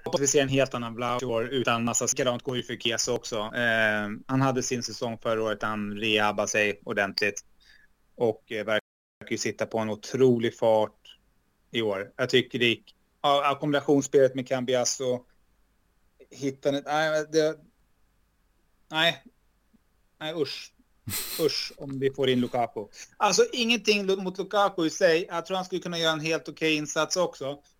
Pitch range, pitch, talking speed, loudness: 115-155 Hz, 130 Hz, 155 wpm, -26 LUFS